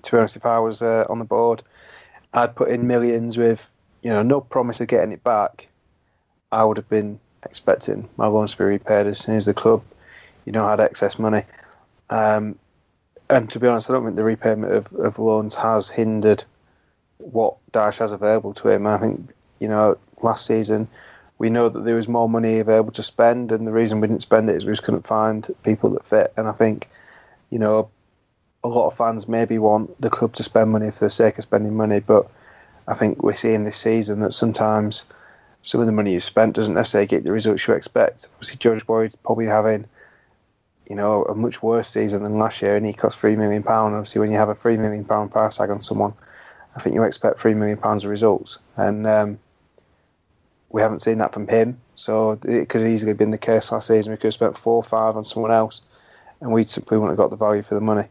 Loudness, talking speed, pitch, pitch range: -20 LUFS, 225 wpm, 110 Hz, 105-115 Hz